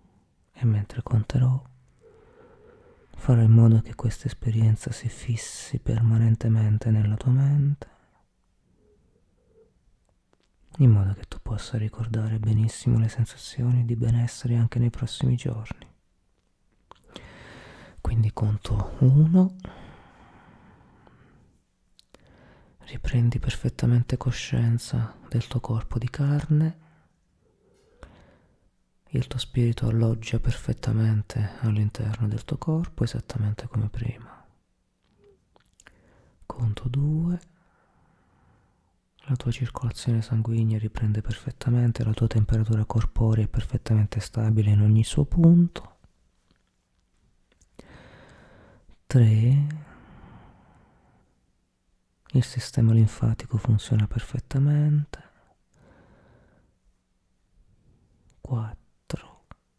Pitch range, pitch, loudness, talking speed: 110-130 Hz, 115 Hz, -24 LUFS, 80 wpm